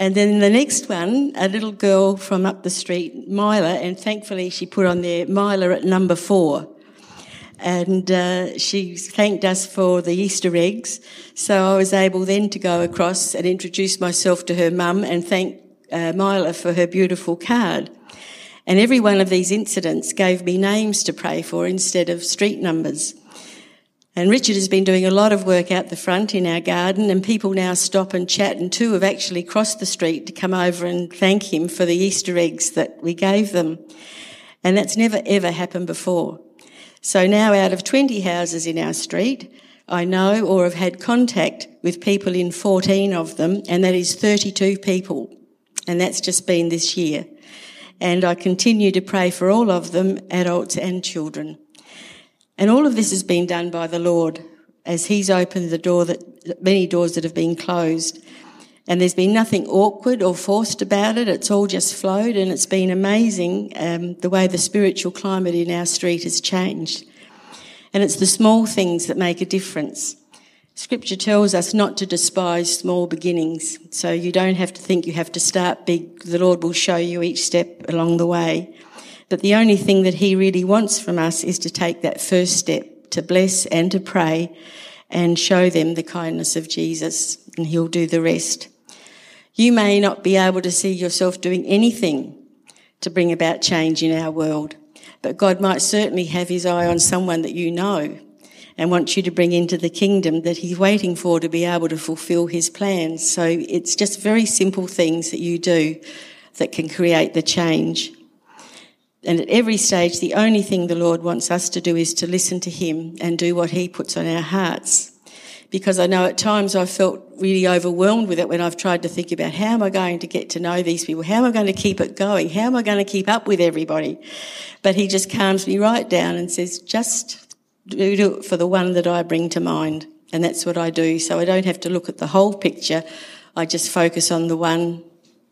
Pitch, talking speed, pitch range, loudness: 180 Hz, 200 wpm, 170-195 Hz, -19 LUFS